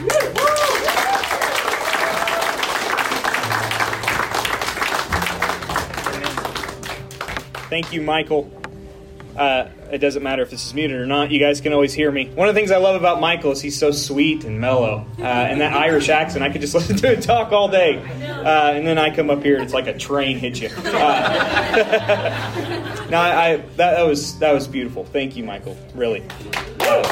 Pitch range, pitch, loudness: 130-160 Hz, 145 Hz, -19 LUFS